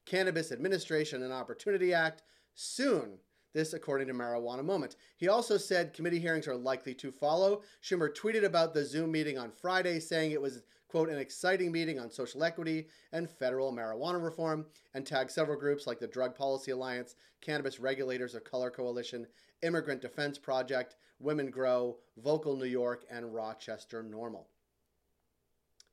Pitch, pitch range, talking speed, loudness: 145 Hz, 125-165 Hz, 155 wpm, -35 LUFS